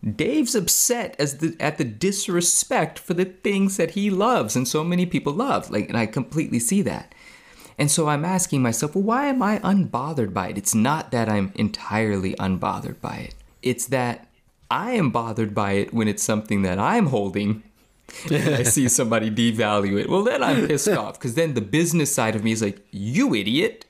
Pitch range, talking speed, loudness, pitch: 110-175 Hz, 200 wpm, -22 LUFS, 130 Hz